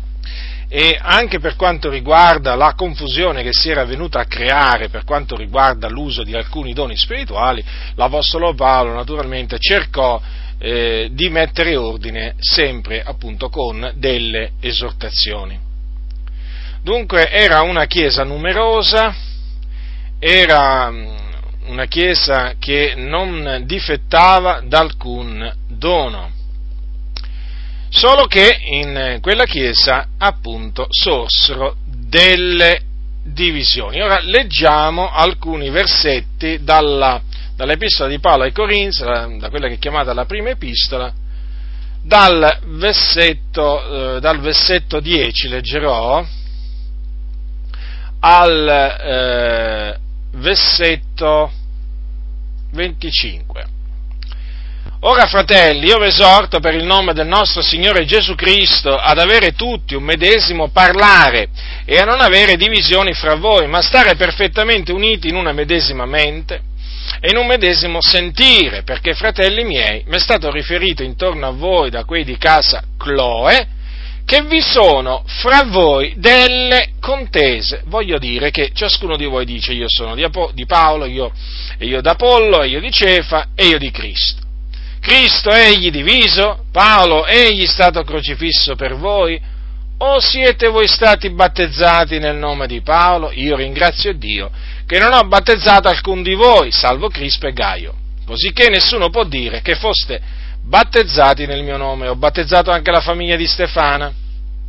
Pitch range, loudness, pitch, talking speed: 115-185 Hz, -12 LUFS, 150 Hz, 125 wpm